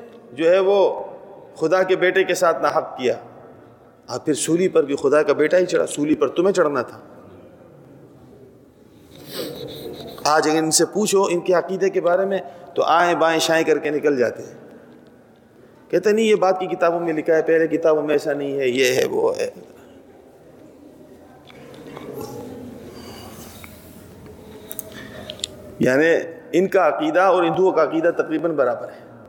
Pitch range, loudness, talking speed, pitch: 155-190 Hz, -19 LUFS, 155 wpm, 170 Hz